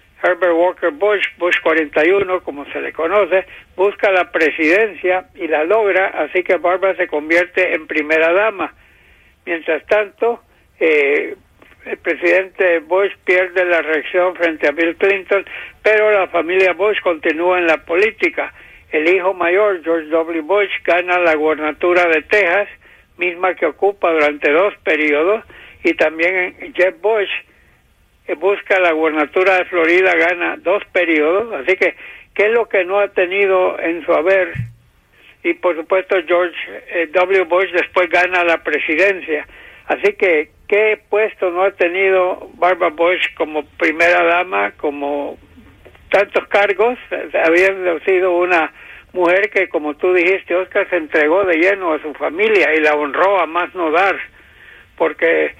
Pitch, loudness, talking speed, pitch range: 180 Hz, -15 LUFS, 145 wpm, 165-195 Hz